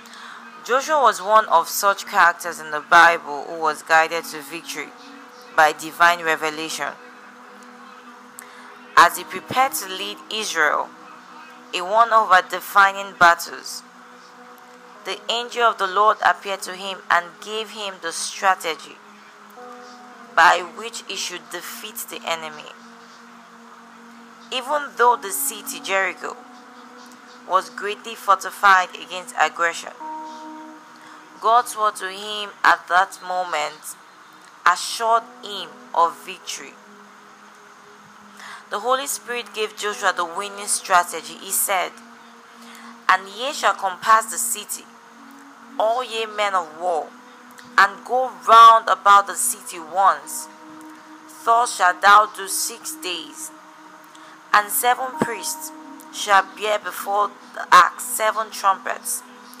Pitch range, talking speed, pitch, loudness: 180-240 Hz, 115 wpm, 205 Hz, -19 LUFS